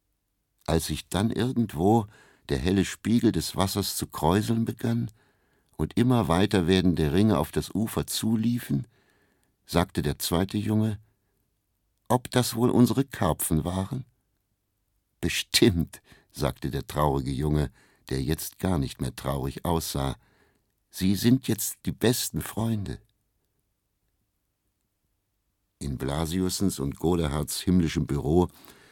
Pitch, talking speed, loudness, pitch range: 100 Hz, 115 wpm, -26 LUFS, 80-110 Hz